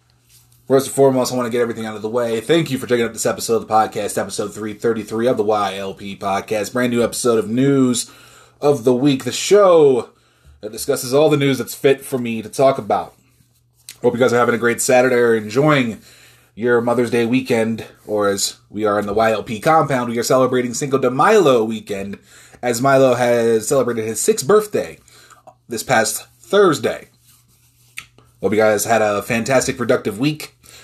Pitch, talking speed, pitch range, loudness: 120 Hz, 190 wpm, 115-130 Hz, -17 LUFS